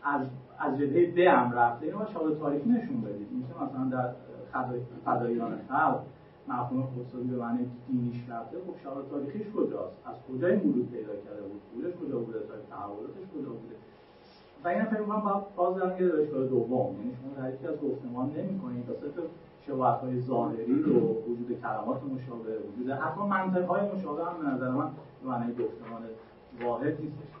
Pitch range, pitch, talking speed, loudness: 120-170 Hz, 130 Hz, 175 wpm, -31 LUFS